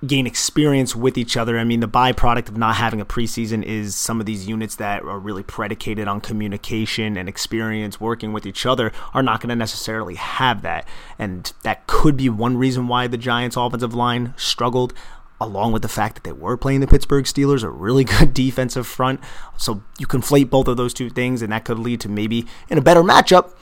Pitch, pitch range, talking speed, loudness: 120 Hz, 110-130 Hz, 215 wpm, -19 LUFS